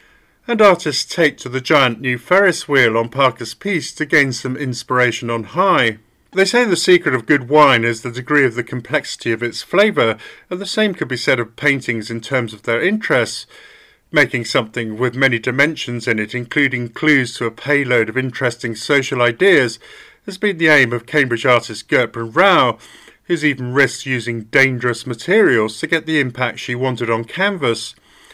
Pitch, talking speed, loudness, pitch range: 130 Hz, 180 wpm, -16 LUFS, 120-155 Hz